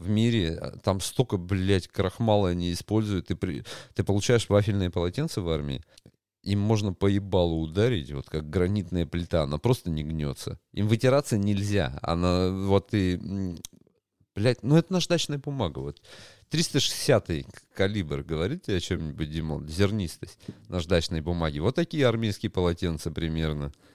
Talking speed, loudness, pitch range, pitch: 140 wpm, -27 LUFS, 85-110 Hz, 95 Hz